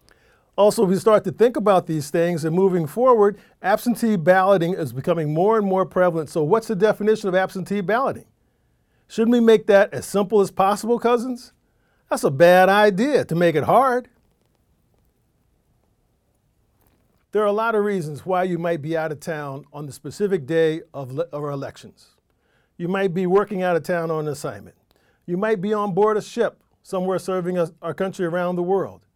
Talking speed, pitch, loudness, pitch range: 185 wpm, 185 Hz, -20 LUFS, 165-210 Hz